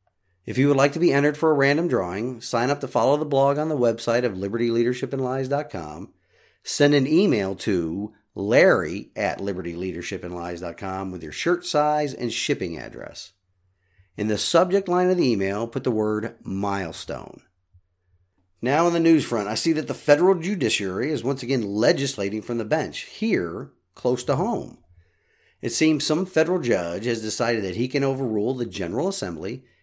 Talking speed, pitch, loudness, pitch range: 165 wpm, 120 Hz, -23 LUFS, 100-145 Hz